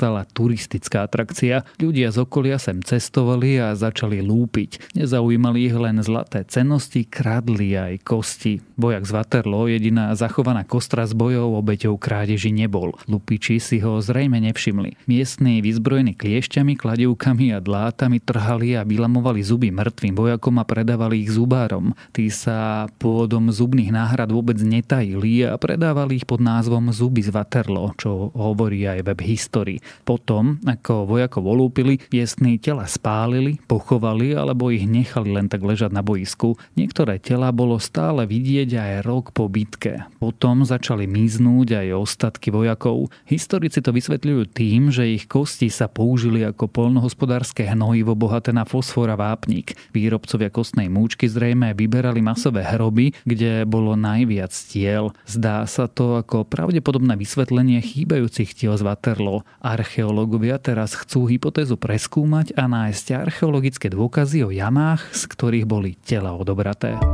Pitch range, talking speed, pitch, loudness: 110-125 Hz, 140 wpm, 115 Hz, -20 LUFS